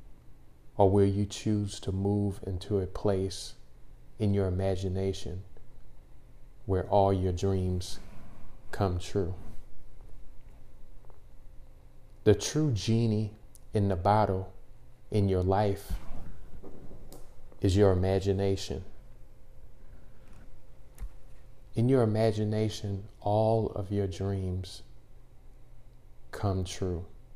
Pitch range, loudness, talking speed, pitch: 95-110 Hz, -30 LUFS, 85 wpm, 100 Hz